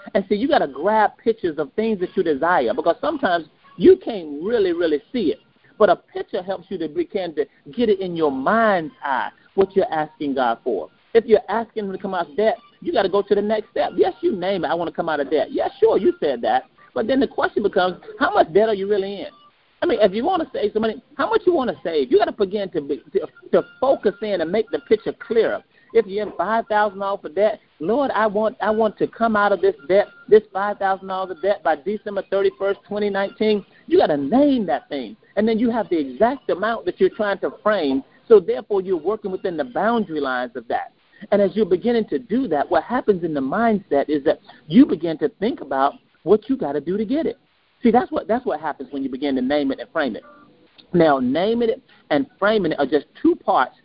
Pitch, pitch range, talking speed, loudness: 210 Hz, 190-250 Hz, 240 wpm, -21 LUFS